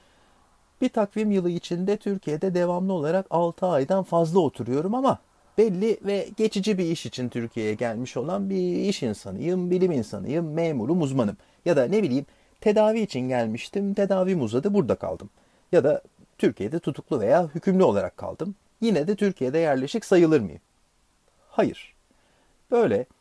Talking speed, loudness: 140 wpm, -25 LUFS